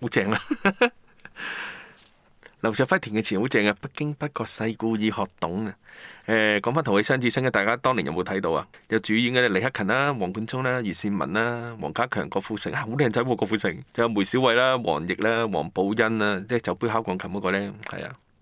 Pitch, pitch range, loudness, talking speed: 115 Hz, 105-130 Hz, -25 LUFS, 340 characters per minute